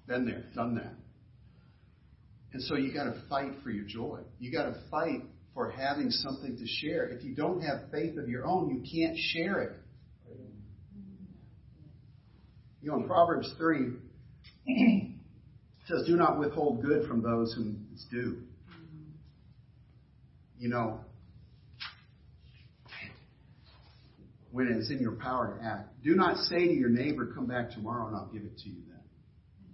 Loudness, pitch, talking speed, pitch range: -32 LUFS, 120 Hz, 150 wpm, 110-140 Hz